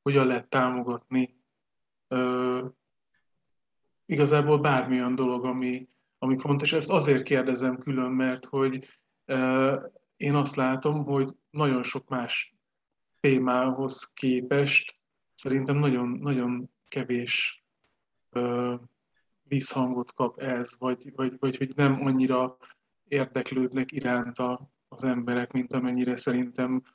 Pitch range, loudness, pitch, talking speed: 125-135 Hz, -27 LUFS, 130 Hz, 105 wpm